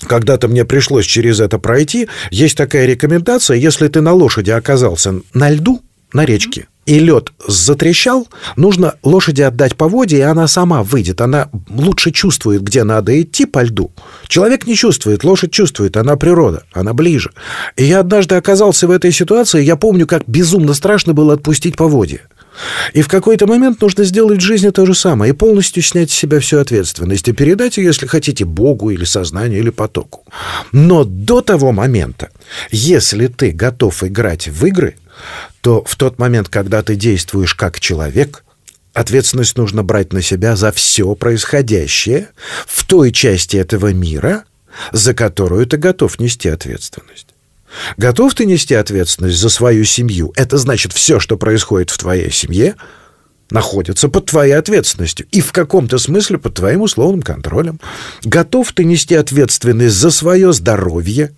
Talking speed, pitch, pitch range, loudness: 160 wpm, 135 Hz, 110-170 Hz, -11 LUFS